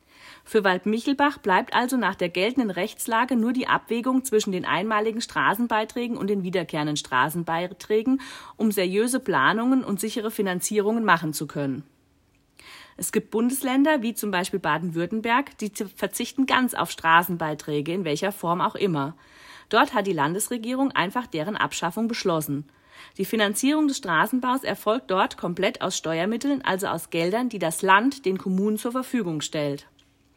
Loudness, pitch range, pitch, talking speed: -24 LUFS, 170-235 Hz, 205 Hz, 145 wpm